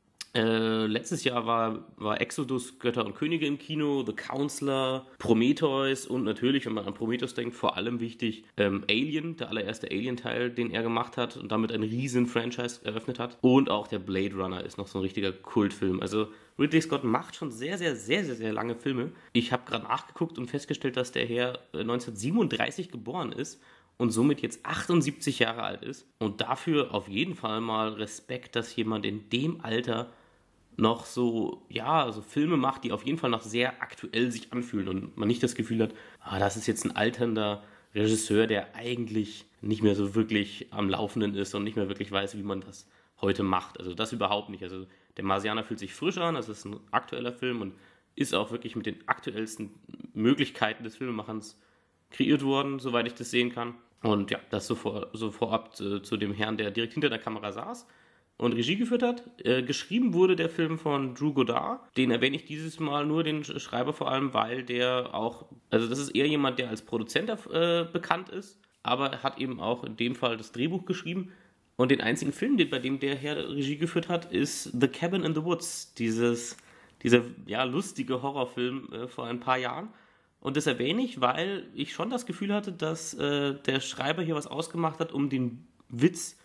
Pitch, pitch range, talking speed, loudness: 120 Hz, 110-145 Hz, 200 wpm, -30 LUFS